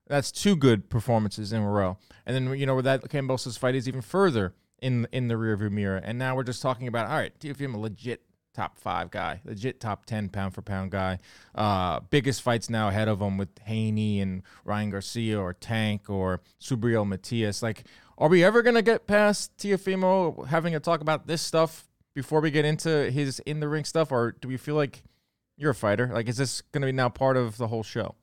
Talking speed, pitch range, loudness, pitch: 215 wpm, 105-145 Hz, -27 LUFS, 120 Hz